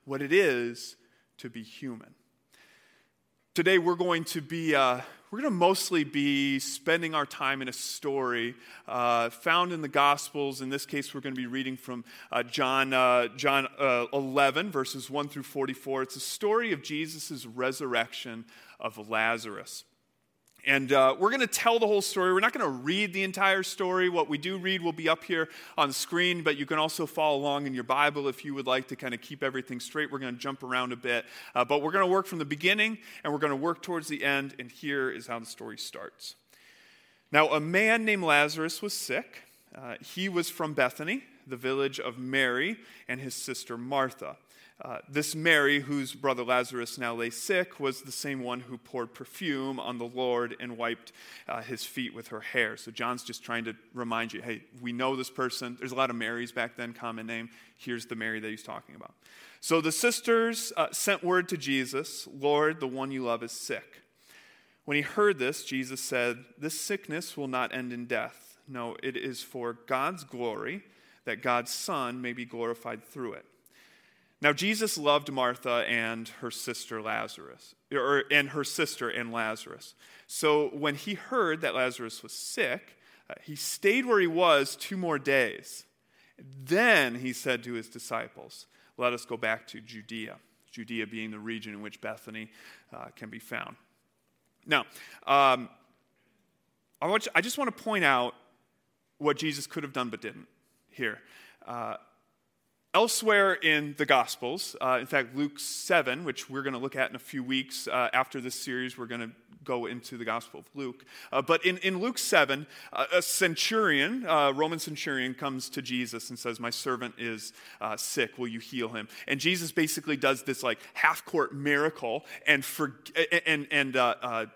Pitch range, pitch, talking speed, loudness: 120-155 Hz, 135 Hz, 190 wpm, -29 LUFS